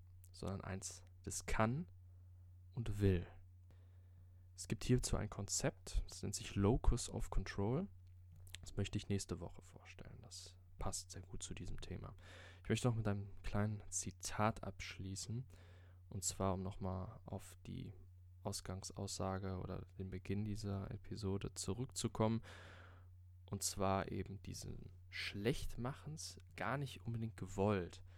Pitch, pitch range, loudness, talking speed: 95 Hz, 90-105 Hz, -43 LUFS, 130 wpm